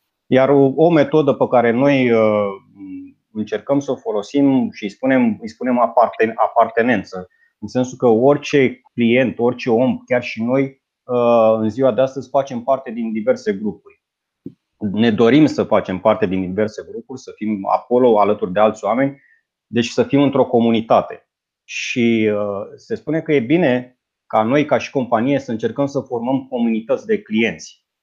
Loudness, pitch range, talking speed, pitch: -17 LUFS, 115-145 Hz, 155 wpm, 130 Hz